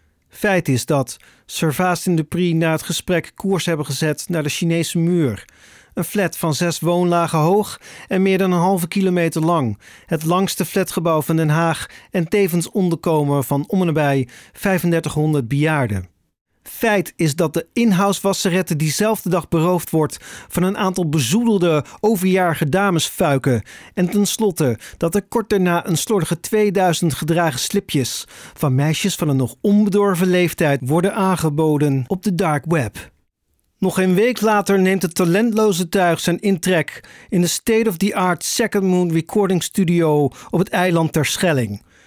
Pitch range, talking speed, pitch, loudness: 155-190 Hz, 150 wpm, 175 Hz, -18 LUFS